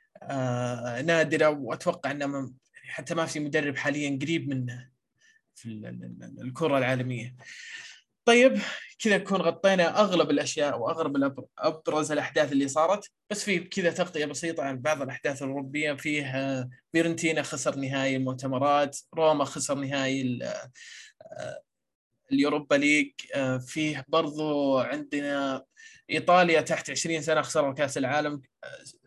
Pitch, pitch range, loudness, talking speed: 150 Hz, 135-170 Hz, -27 LUFS, 110 wpm